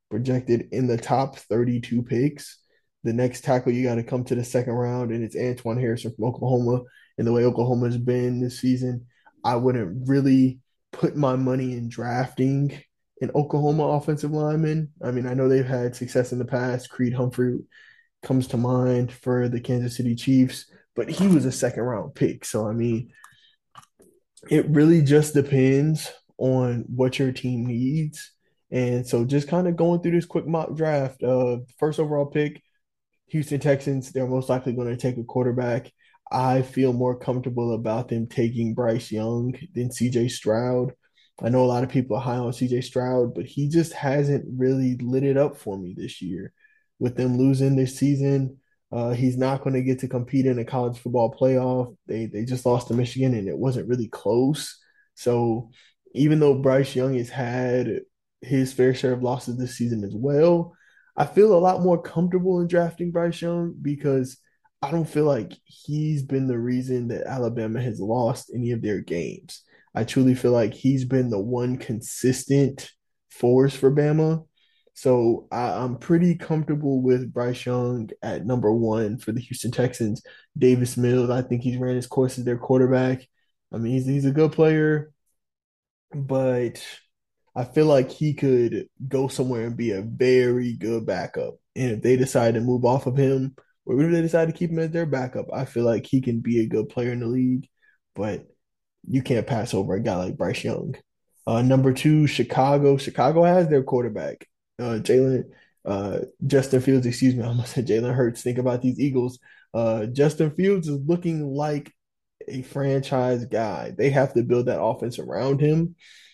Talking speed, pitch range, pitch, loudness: 185 wpm, 120-140 Hz, 130 Hz, -23 LUFS